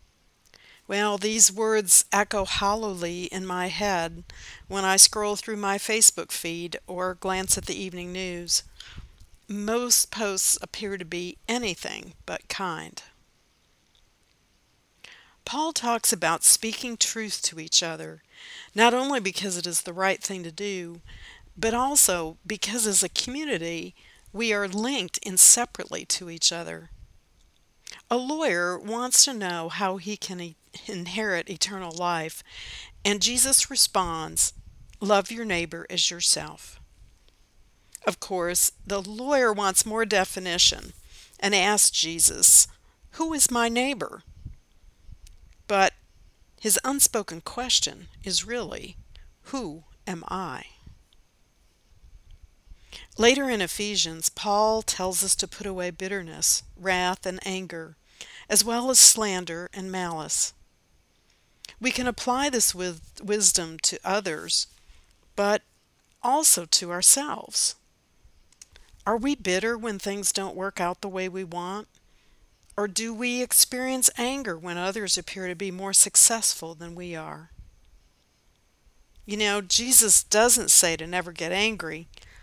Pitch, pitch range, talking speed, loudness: 190 Hz, 170-220 Hz, 125 wpm, -22 LUFS